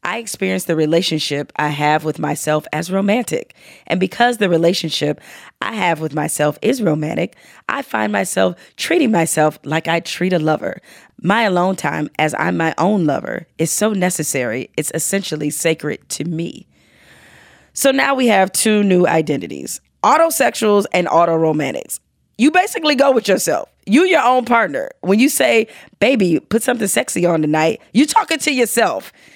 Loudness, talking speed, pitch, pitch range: -16 LUFS, 160 wpm, 180 Hz, 155-225 Hz